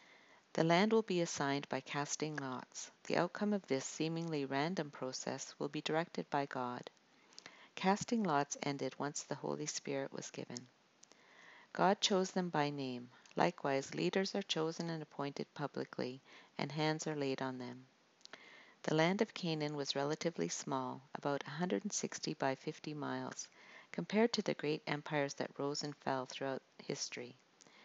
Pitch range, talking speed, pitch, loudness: 135-165 Hz, 150 wpm, 150 Hz, -39 LUFS